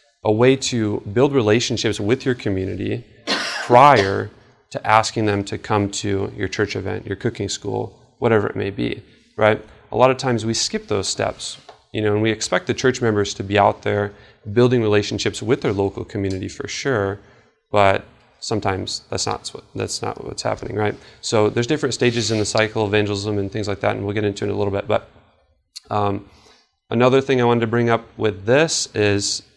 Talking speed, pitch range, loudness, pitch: 200 wpm, 100-120 Hz, -20 LUFS, 105 Hz